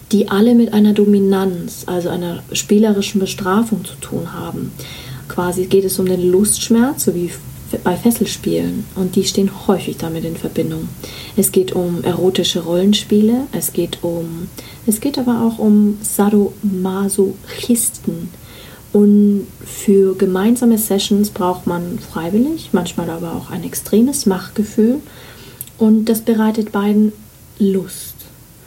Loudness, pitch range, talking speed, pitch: -16 LUFS, 180-215 Hz, 130 wpm, 195 Hz